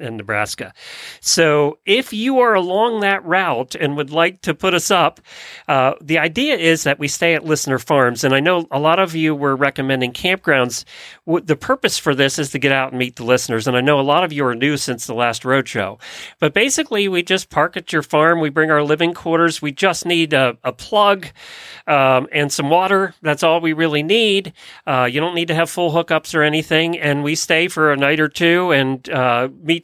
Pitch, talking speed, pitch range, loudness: 155 Hz, 220 wpm, 135-175 Hz, -16 LUFS